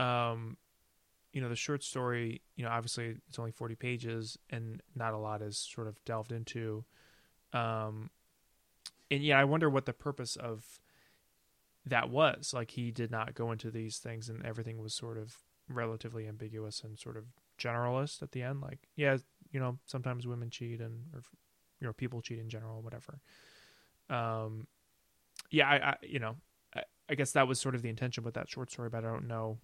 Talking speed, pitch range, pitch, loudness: 190 wpm, 115-130 Hz, 115 Hz, -36 LUFS